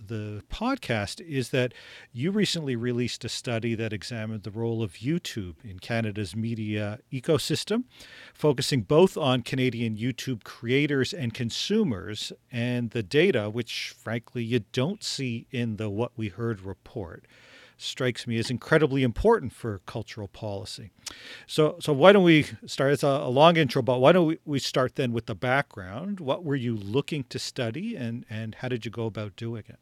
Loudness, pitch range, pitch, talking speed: -27 LUFS, 115-140 Hz, 120 Hz, 170 wpm